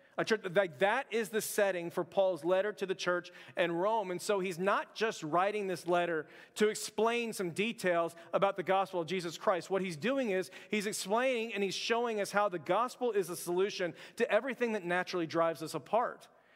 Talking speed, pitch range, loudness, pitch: 200 wpm, 175-215 Hz, -33 LUFS, 190 Hz